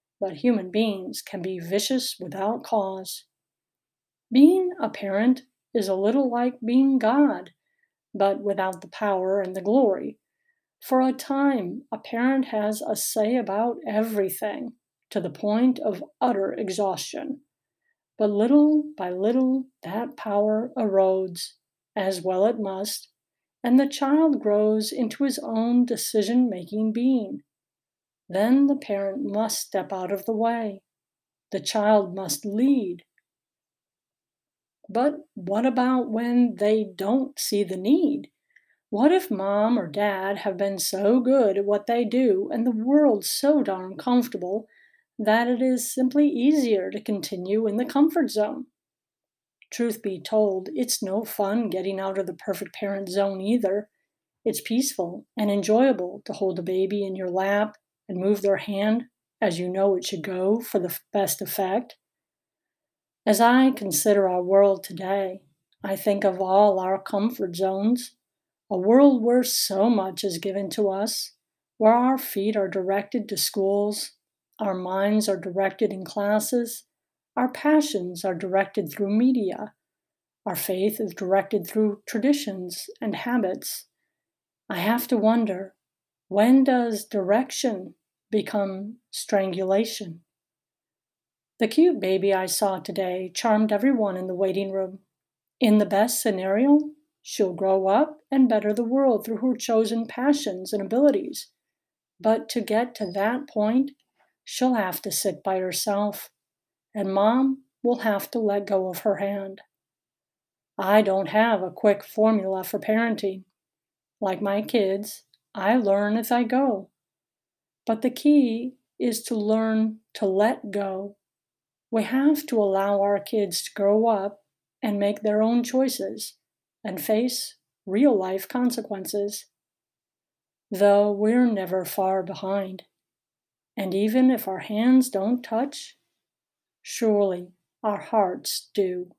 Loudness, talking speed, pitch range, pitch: -24 LUFS, 140 wpm, 195-245 Hz, 210 Hz